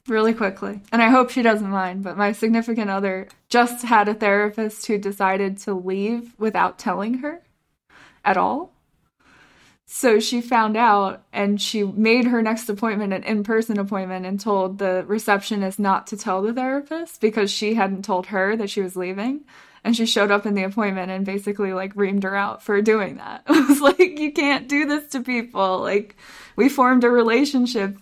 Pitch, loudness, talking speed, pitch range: 215 Hz, -21 LUFS, 185 wpm, 195-235 Hz